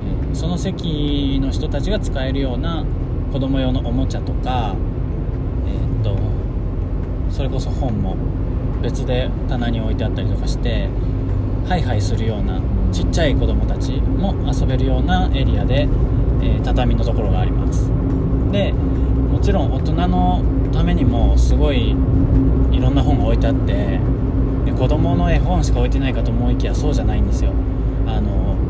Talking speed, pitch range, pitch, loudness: 305 characters per minute, 95-125 Hz, 110 Hz, -19 LUFS